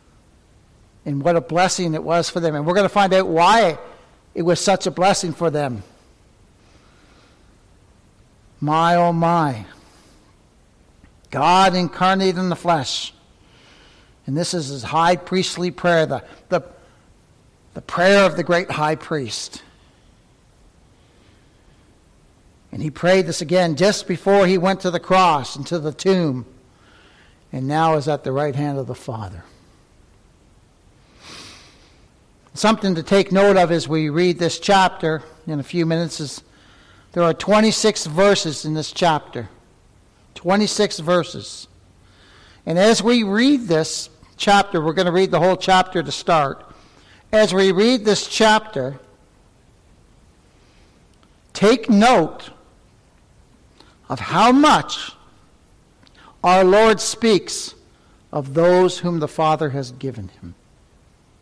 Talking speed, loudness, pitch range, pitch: 130 wpm, -18 LUFS, 145-190 Hz, 170 Hz